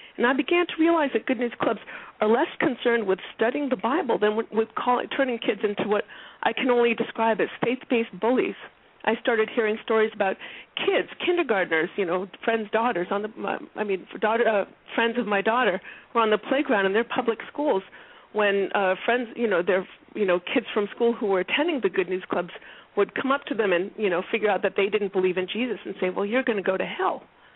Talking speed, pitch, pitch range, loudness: 225 wpm, 225 Hz, 200-245 Hz, -25 LUFS